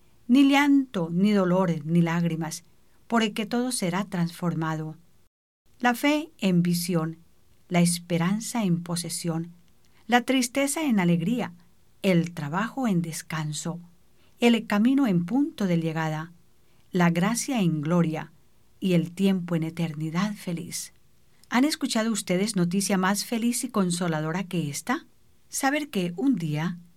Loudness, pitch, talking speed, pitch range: -25 LUFS, 180 Hz, 130 wpm, 170-230 Hz